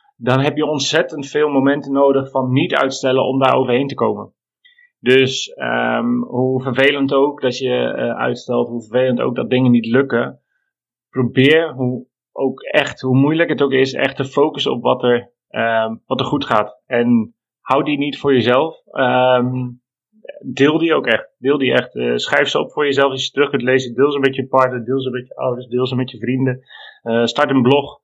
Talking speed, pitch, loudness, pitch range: 205 wpm, 130 Hz, -17 LUFS, 125-140 Hz